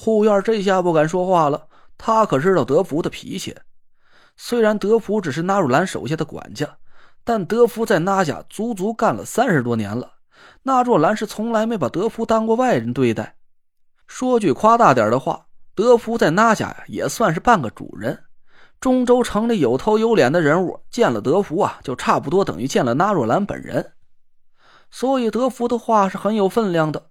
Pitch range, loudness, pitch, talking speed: 190-230 Hz, -19 LUFS, 220 Hz, 275 characters per minute